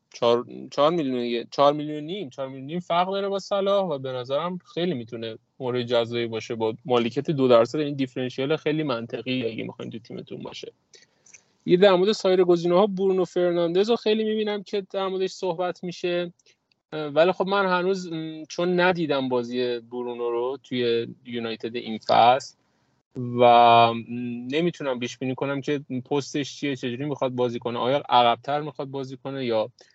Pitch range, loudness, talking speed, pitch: 120-180 Hz, -24 LUFS, 160 wpm, 140 Hz